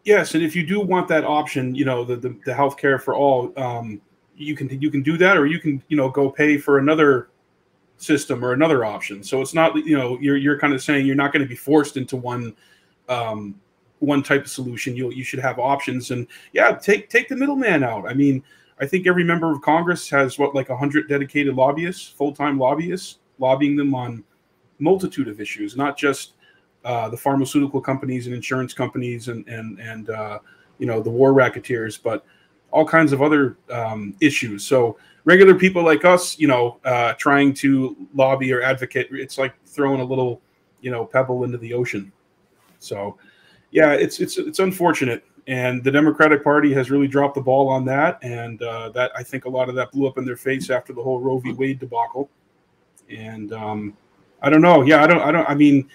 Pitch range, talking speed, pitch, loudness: 125-150 Hz, 205 wpm, 135 Hz, -19 LUFS